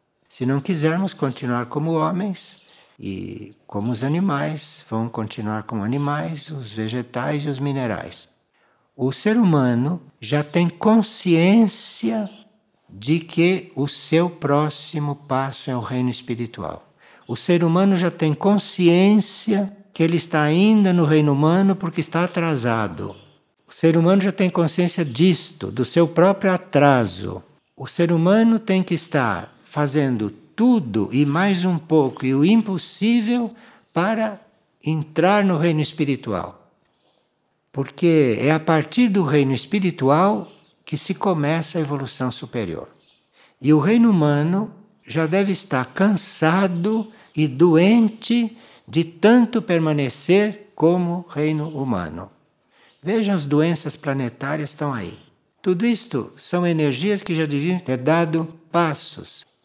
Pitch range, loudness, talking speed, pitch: 140-190 Hz, -20 LUFS, 130 wpm, 160 Hz